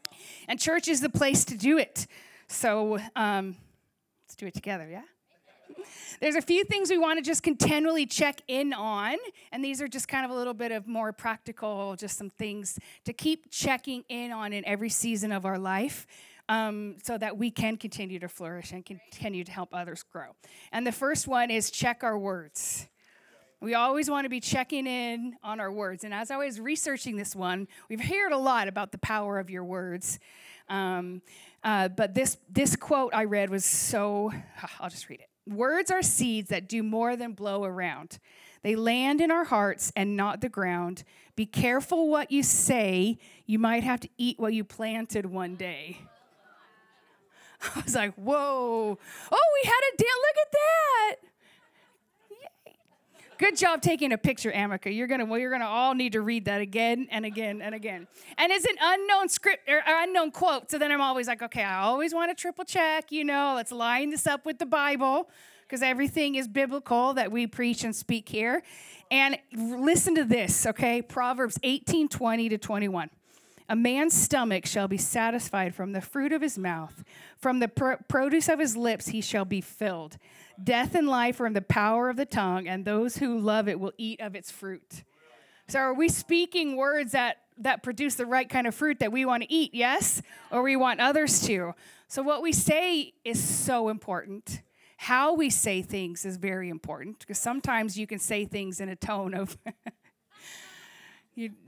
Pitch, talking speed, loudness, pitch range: 230 Hz, 190 wpm, -27 LUFS, 205-275 Hz